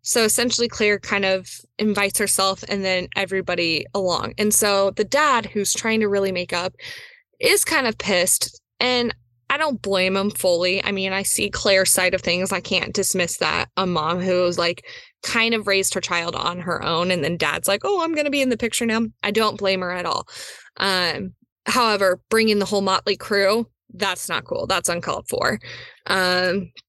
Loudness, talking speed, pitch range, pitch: -20 LUFS, 195 wpm, 180-225 Hz, 195 Hz